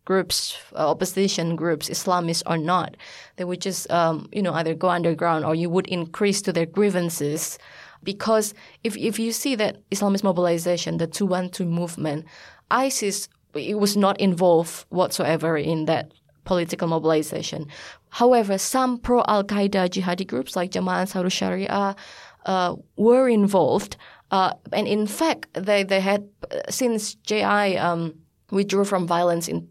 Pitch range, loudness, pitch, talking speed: 170-205 Hz, -23 LUFS, 185 Hz, 150 wpm